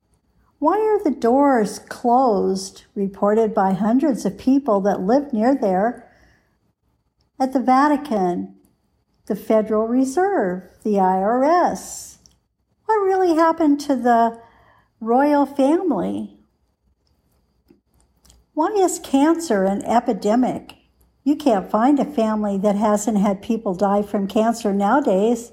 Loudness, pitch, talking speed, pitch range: -19 LUFS, 230 Hz, 110 wpm, 205-275 Hz